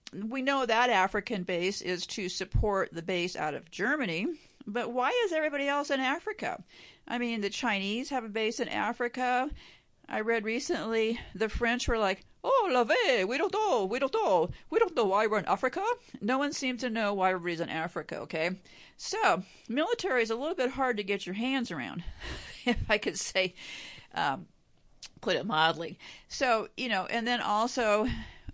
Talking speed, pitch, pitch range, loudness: 185 wpm, 235 Hz, 195-265 Hz, -30 LUFS